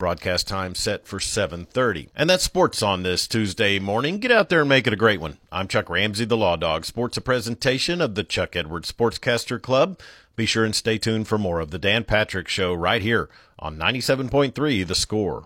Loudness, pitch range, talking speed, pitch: -22 LUFS, 90-125 Hz, 225 wpm, 110 Hz